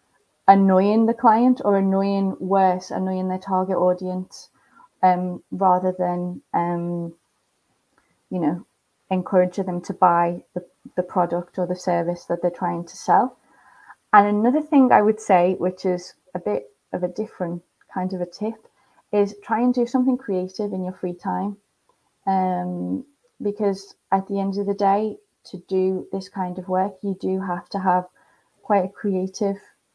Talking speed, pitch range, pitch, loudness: 160 wpm, 180-205 Hz, 190 Hz, -22 LUFS